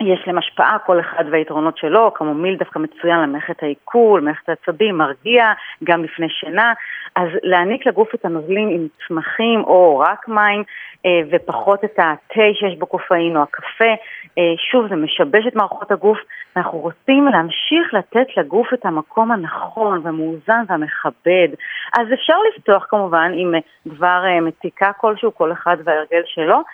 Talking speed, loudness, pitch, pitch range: 145 wpm, -16 LUFS, 180 Hz, 165-215 Hz